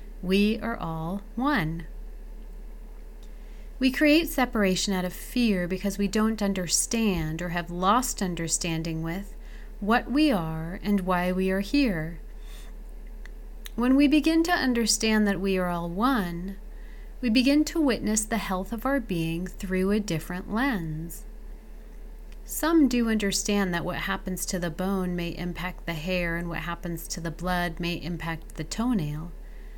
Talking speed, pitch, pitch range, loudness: 145 wpm, 200 Hz, 175-225 Hz, -26 LUFS